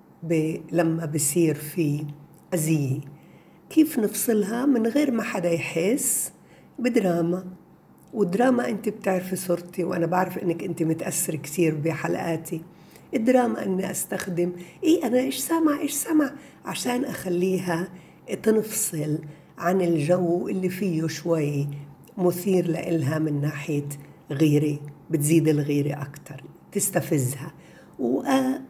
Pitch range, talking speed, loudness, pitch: 160-210 Hz, 110 wpm, -25 LUFS, 175 Hz